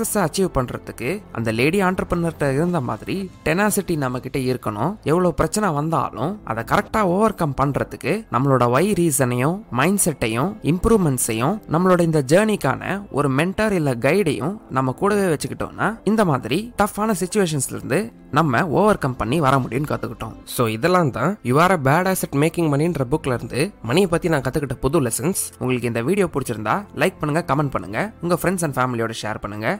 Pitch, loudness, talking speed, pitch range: 160 Hz, -20 LUFS, 150 wpm, 130-185 Hz